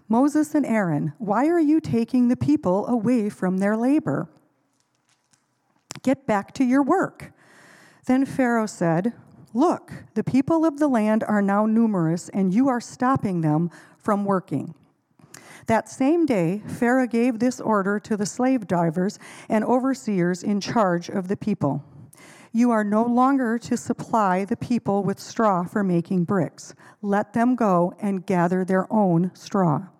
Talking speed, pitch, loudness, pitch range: 150 wpm, 210 Hz, -22 LUFS, 180-245 Hz